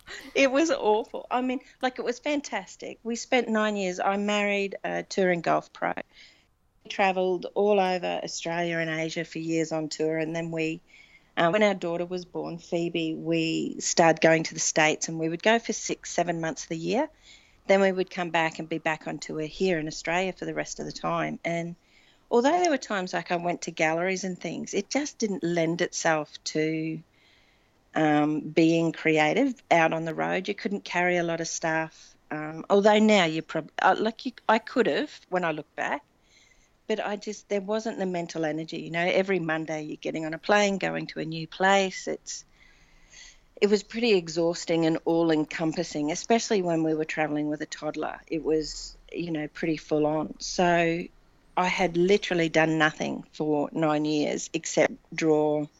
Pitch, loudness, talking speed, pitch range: 170 Hz, -27 LUFS, 190 wpm, 160-200 Hz